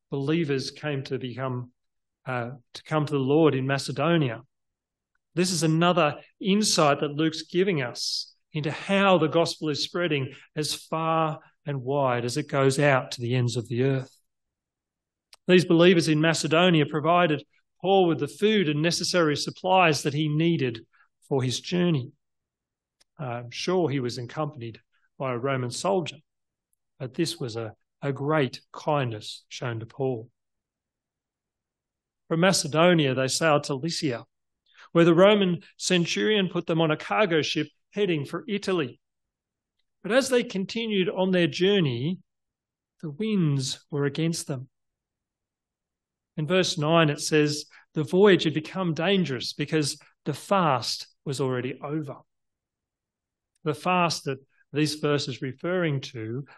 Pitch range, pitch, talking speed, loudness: 135-175 Hz, 155 Hz, 140 wpm, -25 LUFS